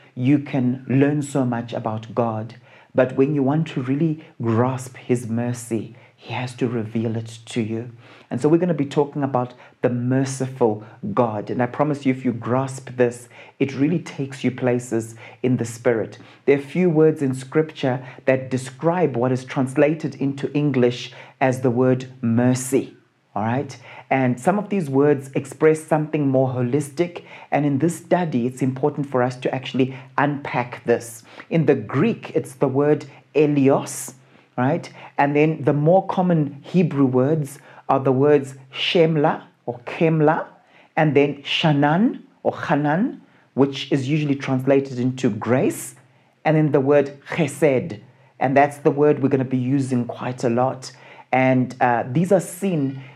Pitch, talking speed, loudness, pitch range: 135 Hz, 165 wpm, -21 LUFS, 125-150 Hz